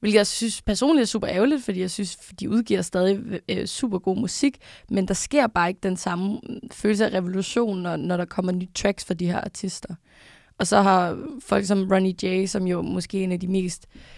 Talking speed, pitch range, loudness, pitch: 220 wpm, 185-220 Hz, -24 LUFS, 195 Hz